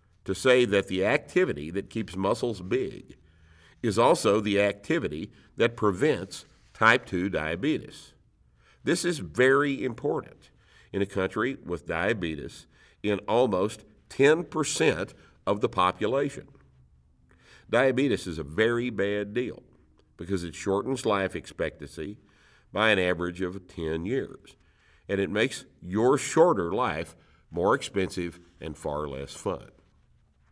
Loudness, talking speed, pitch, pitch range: -27 LUFS, 120 wpm, 95 Hz, 80-105 Hz